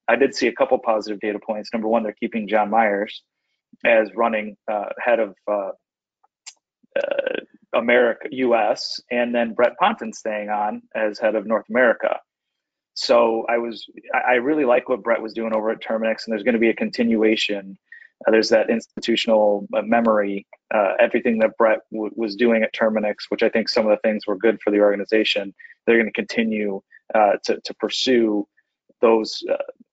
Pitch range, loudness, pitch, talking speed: 105-115 Hz, -21 LUFS, 110 Hz, 175 wpm